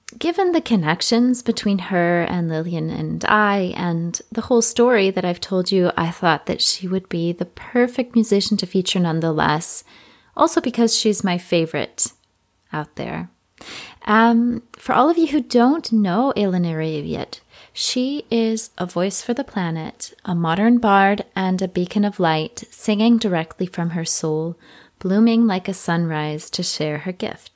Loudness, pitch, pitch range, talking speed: -19 LUFS, 190 Hz, 170-230 Hz, 160 wpm